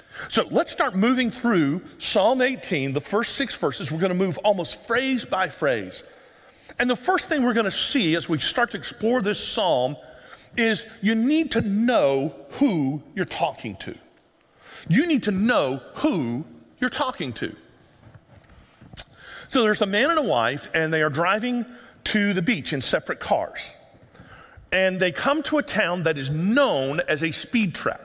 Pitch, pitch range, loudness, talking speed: 215 Hz, 170-250 Hz, -23 LUFS, 175 wpm